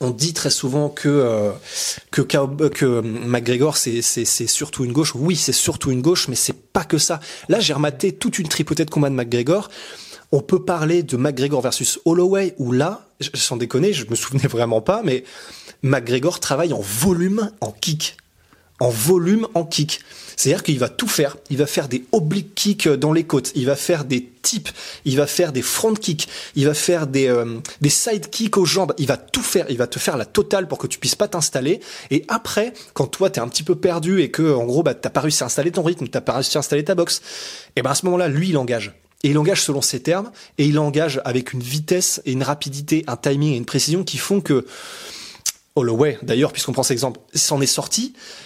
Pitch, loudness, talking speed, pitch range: 145 Hz, -19 LUFS, 235 wpm, 130-175 Hz